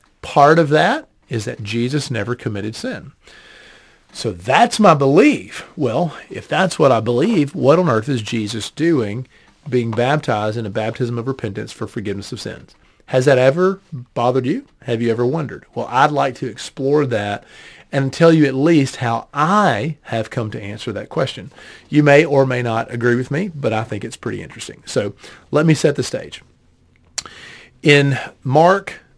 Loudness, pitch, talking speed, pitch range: -17 LUFS, 125 Hz, 175 wpm, 115-145 Hz